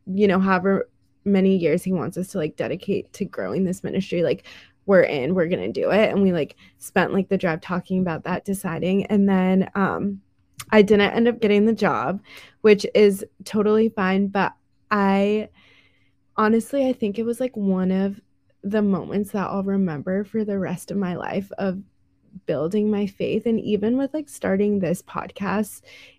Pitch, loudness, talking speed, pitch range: 195 Hz, -22 LUFS, 180 wpm, 185-210 Hz